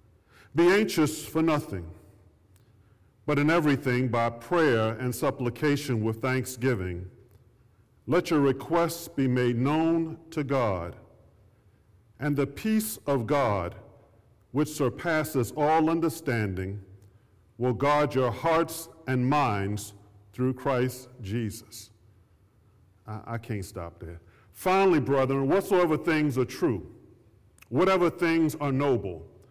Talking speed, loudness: 110 wpm, -27 LUFS